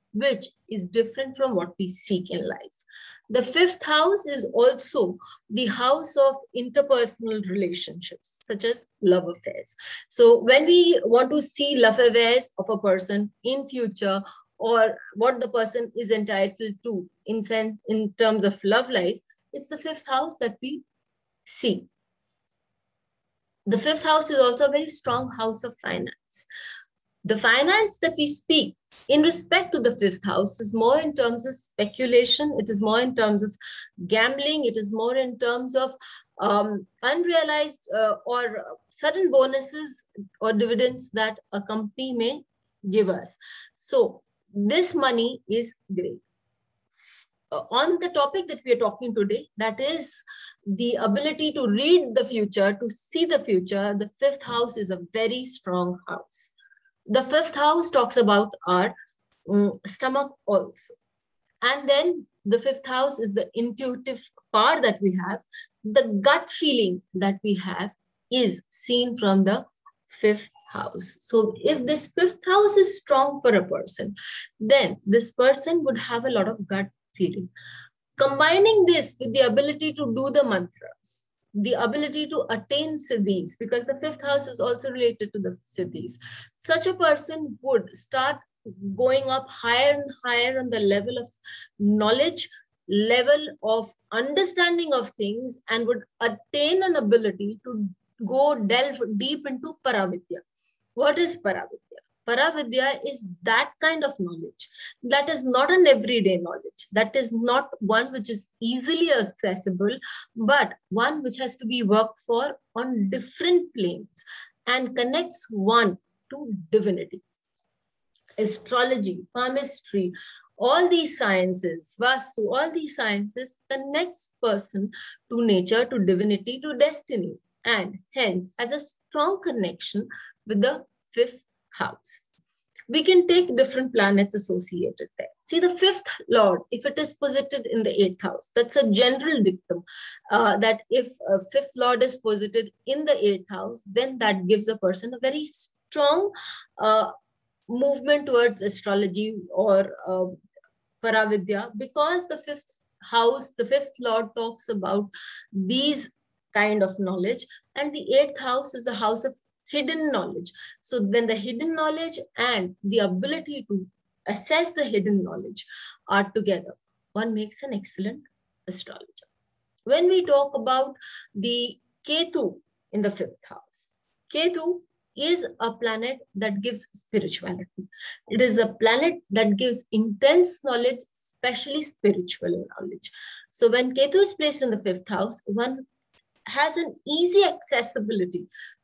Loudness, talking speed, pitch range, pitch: -24 LUFS, 145 wpm, 210-285 Hz, 245 Hz